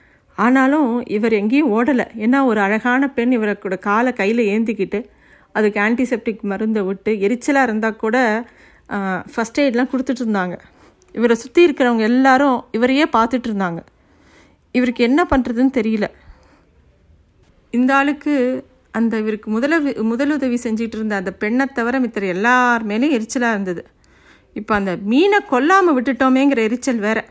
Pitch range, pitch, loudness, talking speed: 210-260 Hz, 235 Hz, -17 LUFS, 125 wpm